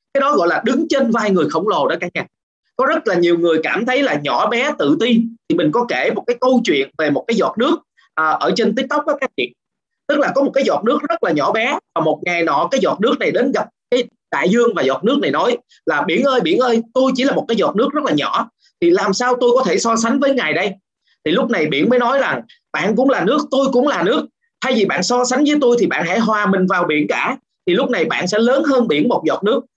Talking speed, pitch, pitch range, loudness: 280 wpm, 250 Hz, 220-275 Hz, -16 LUFS